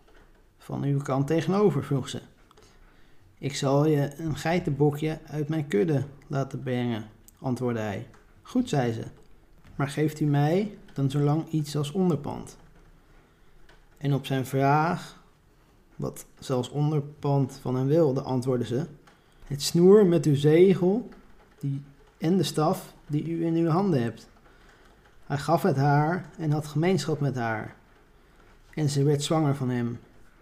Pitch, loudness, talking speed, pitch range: 145 Hz, -26 LUFS, 140 wpm, 130-160 Hz